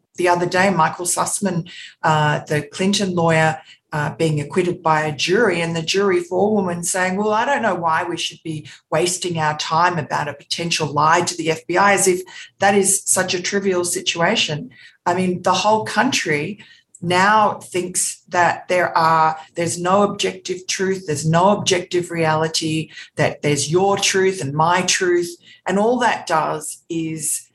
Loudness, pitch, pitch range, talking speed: -18 LUFS, 175 Hz, 160-190 Hz, 165 wpm